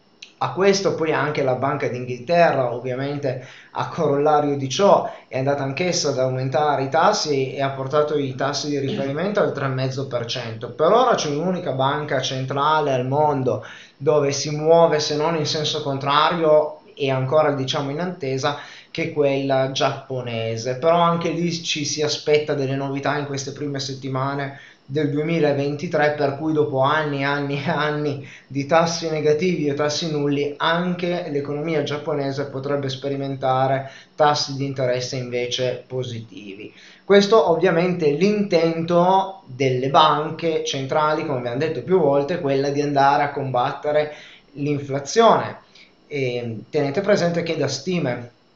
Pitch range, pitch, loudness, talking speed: 135-155 Hz, 145 Hz, -21 LUFS, 140 wpm